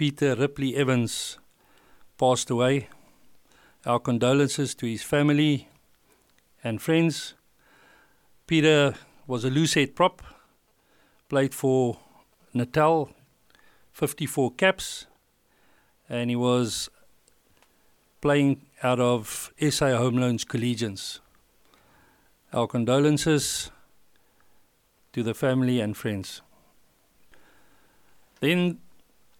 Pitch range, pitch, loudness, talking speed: 120-145 Hz, 130 Hz, -25 LUFS, 80 wpm